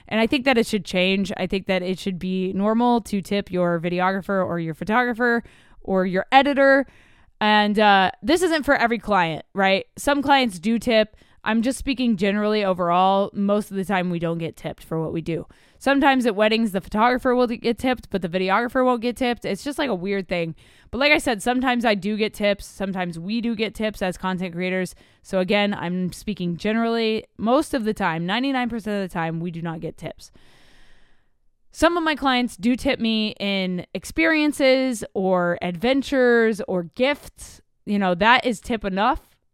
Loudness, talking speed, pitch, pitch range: -21 LUFS, 195 wpm, 210 Hz, 185-245 Hz